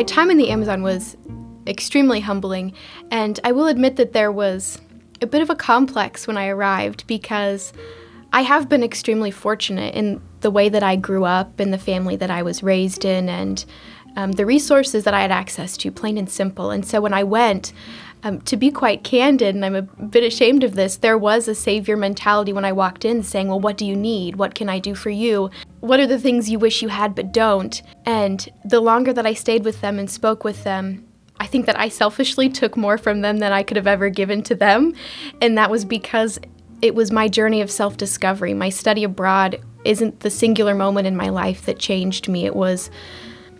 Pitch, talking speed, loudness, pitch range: 210 Hz, 220 wpm, -19 LUFS, 190-225 Hz